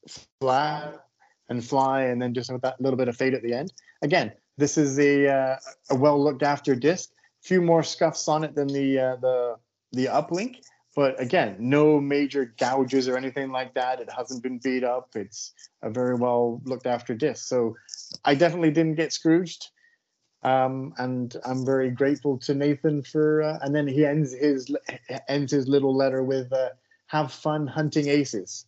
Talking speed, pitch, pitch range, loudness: 185 wpm, 135 Hz, 130-150 Hz, -25 LUFS